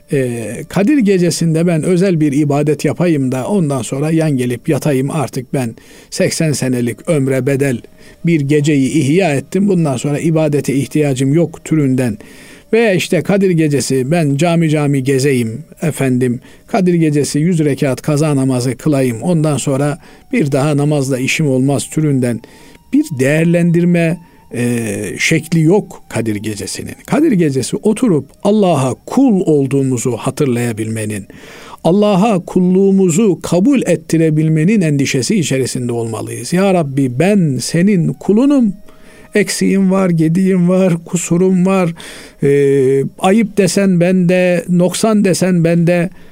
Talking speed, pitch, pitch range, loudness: 120 wpm, 155 Hz, 135-185 Hz, -14 LUFS